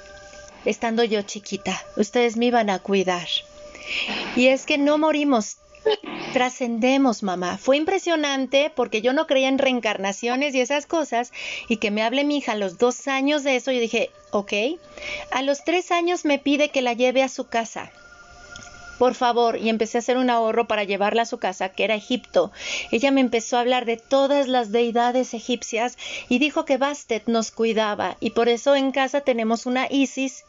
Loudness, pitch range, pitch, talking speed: -22 LUFS, 230-280 Hz, 250 Hz, 185 wpm